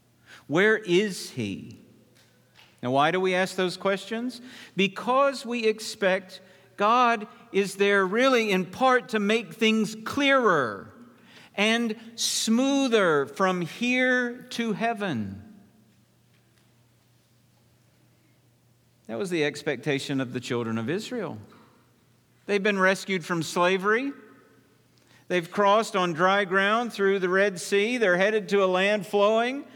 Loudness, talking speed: -25 LUFS, 115 wpm